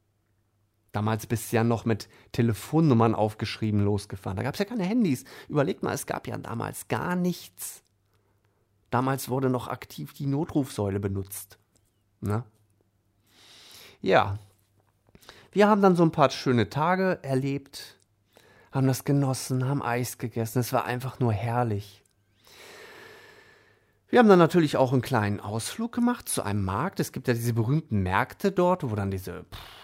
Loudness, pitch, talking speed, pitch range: -26 LUFS, 115 Hz, 150 wpm, 105-140 Hz